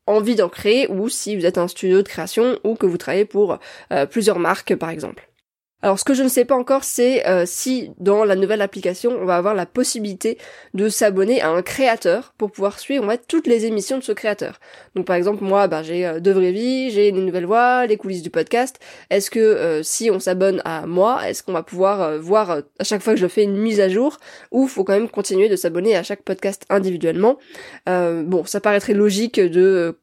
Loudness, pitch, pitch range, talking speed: -19 LUFS, 200 Hz, 185-225 Hz, 230 wpm